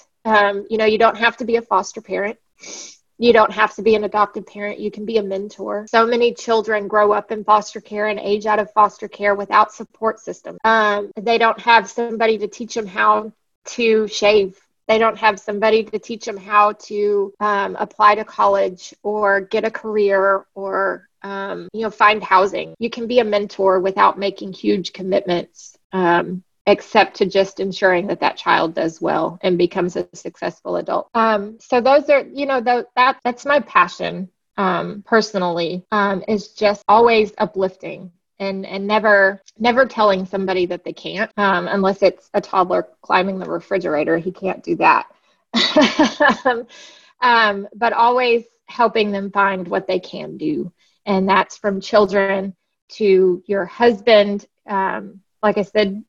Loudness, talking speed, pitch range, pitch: -18 LUFS, 170 wpm, 195-225 Hz, 210 Hz